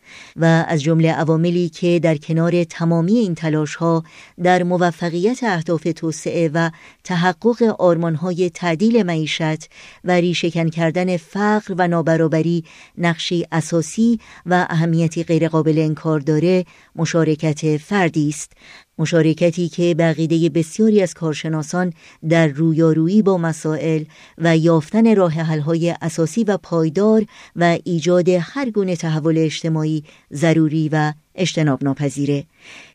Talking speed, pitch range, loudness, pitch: 115 wpm, 160-180 Hz, -18 LUFS, 165 Hz